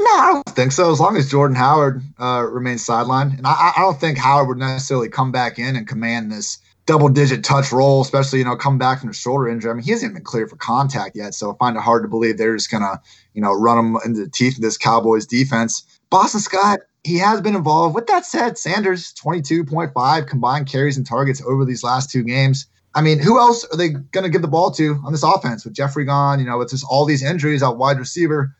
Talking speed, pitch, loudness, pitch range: 245 wpm, 135 Hz, -17 LUFS, 120-155 Hz